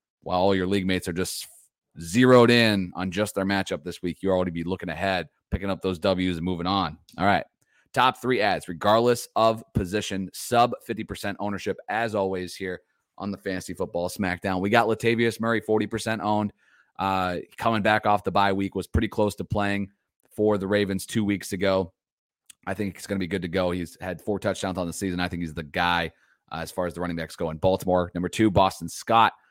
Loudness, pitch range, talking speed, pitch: -25 LUFS, 90-105 Hz, 215 wpm, 95 Hz